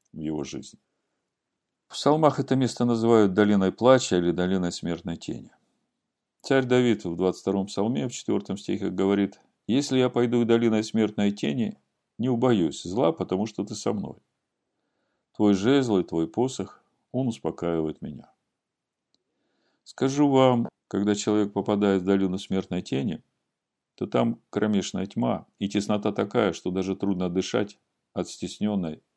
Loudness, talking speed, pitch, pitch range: -25 LUFS, 140 wpm, 105 Hz, 95-120 Hz